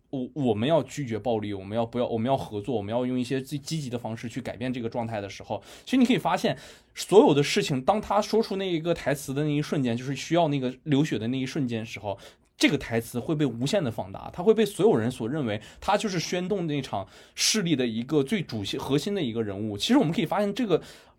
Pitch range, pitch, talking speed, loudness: 115-165 Hz, 135 Hz, 380 characters per minute, -27 LUFS